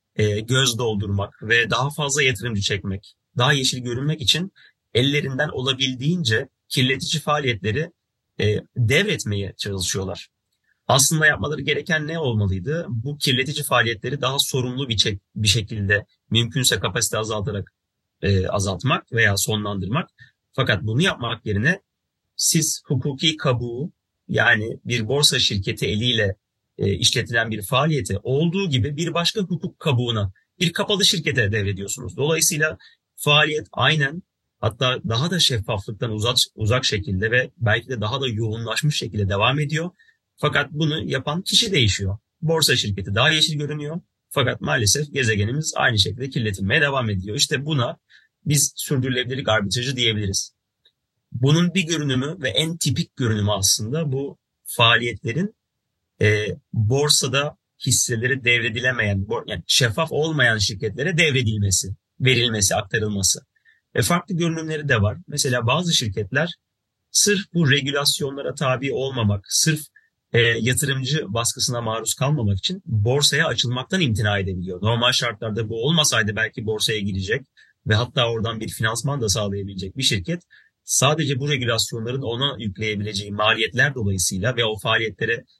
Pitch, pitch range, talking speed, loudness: 125 Hz, 110-150 Hz, 125 wpm, -21 LUFS